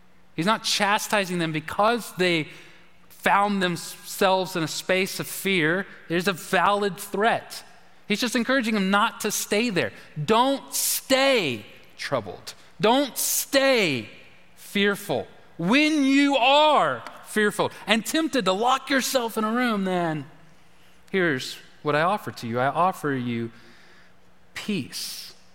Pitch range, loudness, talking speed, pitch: 170-235 Hz, -23 LUFS, 125 wpm, 200 Hz